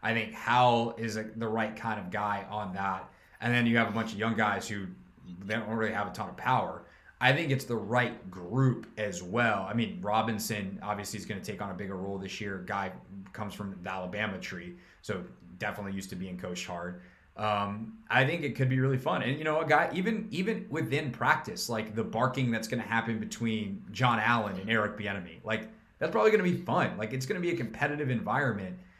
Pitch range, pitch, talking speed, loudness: 100-120 Hz, 110 Hz, 225 wpm, -31 LUFS